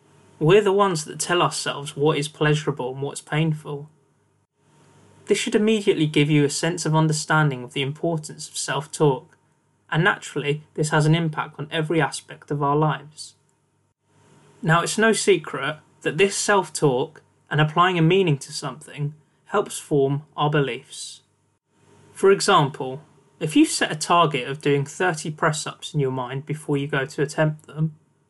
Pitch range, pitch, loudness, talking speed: 140-165 Hz, 150 Hz, -22 LUFS, 160 wpm